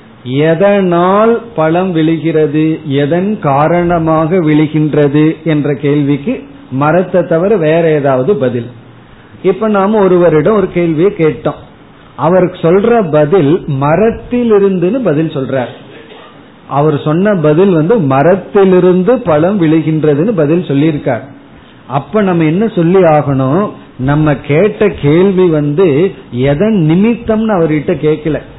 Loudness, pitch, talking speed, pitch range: -10 LUFS, 160 Hz, 95 wpm, 150-190 Hz